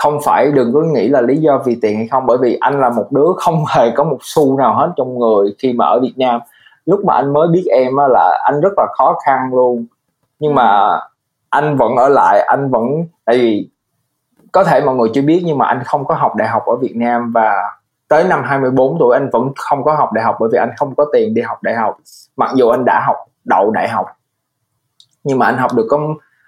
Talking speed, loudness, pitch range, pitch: 245 wpm, -13 LUFS, 120-145 Hz, 130 Hz